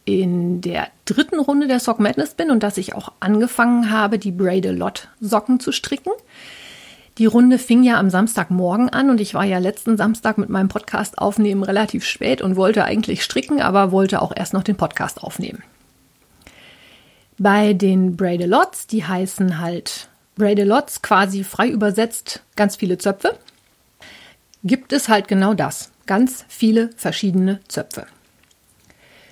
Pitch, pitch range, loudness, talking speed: 210 Hz, 190-230 Hz, -18 LUFS, 155 wpm